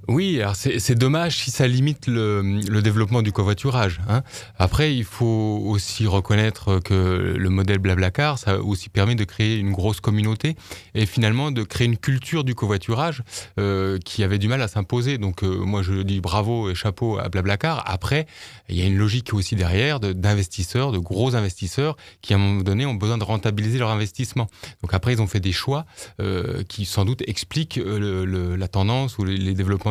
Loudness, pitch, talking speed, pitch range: -22 LUFS, 105 Hz, 205 wpm, 100-120 Hz